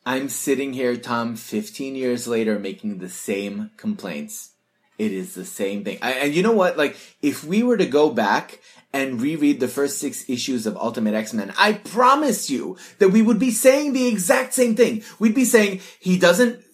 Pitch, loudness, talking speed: 175 Hz, -21 LUFS, 195 wpm